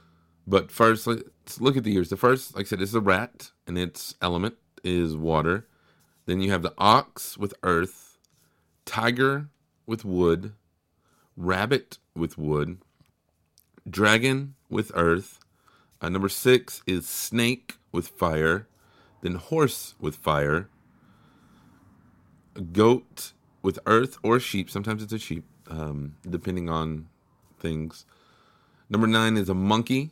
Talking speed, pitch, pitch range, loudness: 130 wpm, 95 Hz, 85-115 Hz, -25 LUFS